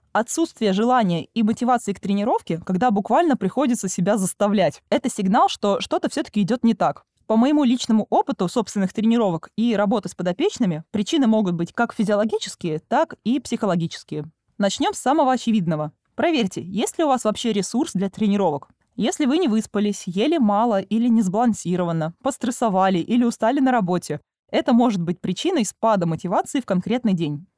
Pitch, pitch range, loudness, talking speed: 215 Hz, 190-245 Hz, -21 LUFS, 160 wpm